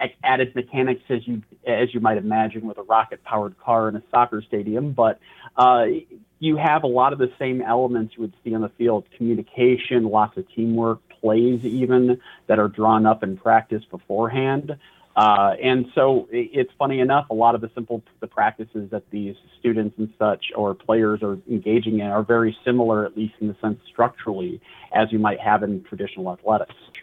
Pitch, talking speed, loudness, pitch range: 115 Hz, 190 wpm, -21 LUFS, 110-125 Hz